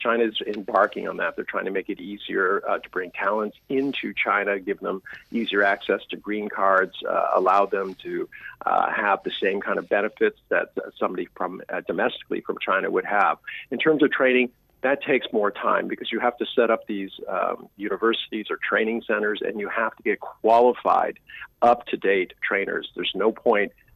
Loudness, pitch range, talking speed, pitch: -24 LUFS, 100-140 Hz, 185 wpm, 115 Hz